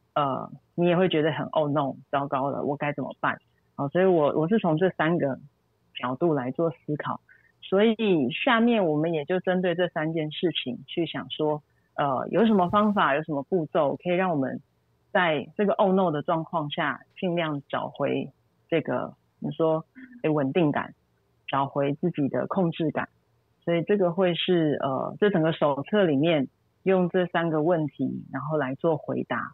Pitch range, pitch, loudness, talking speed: 150-185 Hz, 165 Hz, -26 LUFS, 260 characters per minute